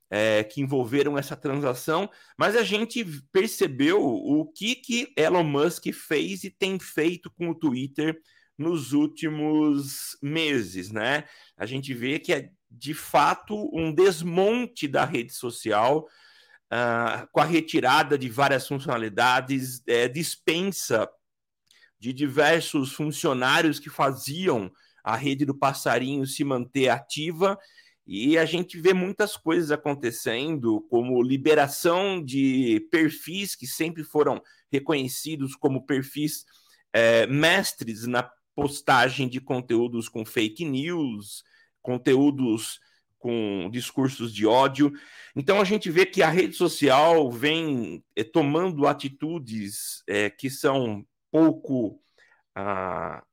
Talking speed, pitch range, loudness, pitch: 120 wpm, 130-170 Hz, -25 LUFS, 145 Hz